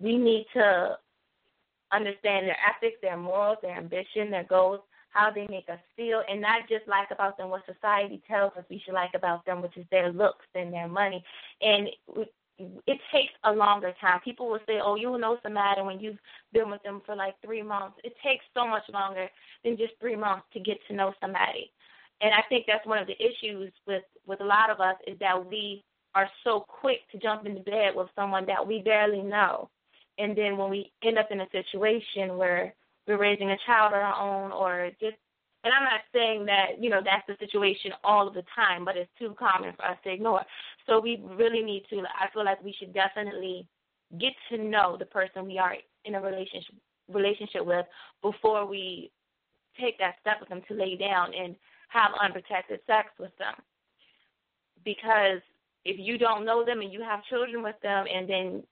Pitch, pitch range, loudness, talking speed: 205 Hz, 190-215 Hz, -28 LUFS, 200 wpm